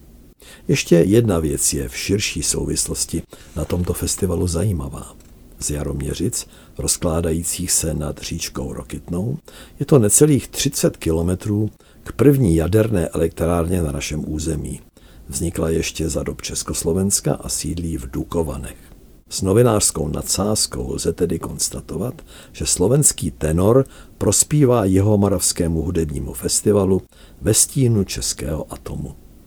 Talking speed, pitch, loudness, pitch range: 115 wpm, 85 Hz, -19 LUFS, 75-100 Hz